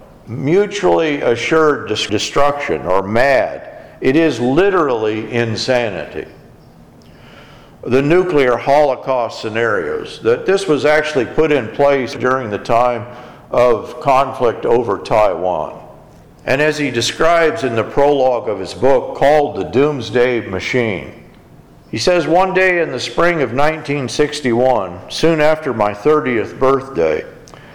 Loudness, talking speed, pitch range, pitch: -15 LUFS, 120 wpm, 120-160 Hz, 145 Hz